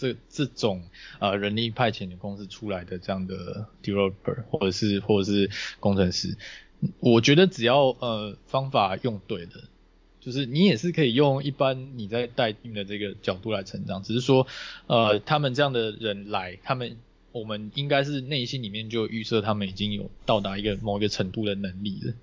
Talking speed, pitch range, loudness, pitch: 300 characters per minute, 100-130 Hz, -26 LUFS, 110 Hz